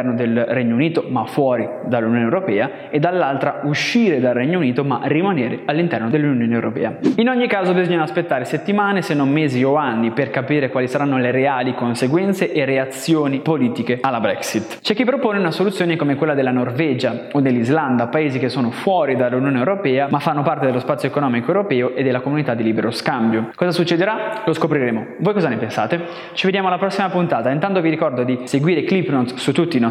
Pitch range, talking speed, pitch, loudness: 125-175 Hz, 190 wpm, 145 Hz, -18 LUFS